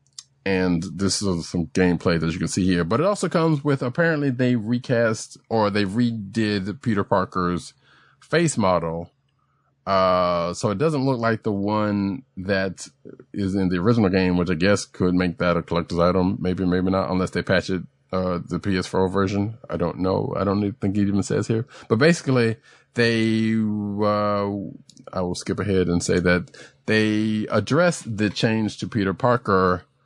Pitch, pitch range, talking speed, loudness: 100 Hz, 90-115 Hz, 175 wpm, -22 LUFS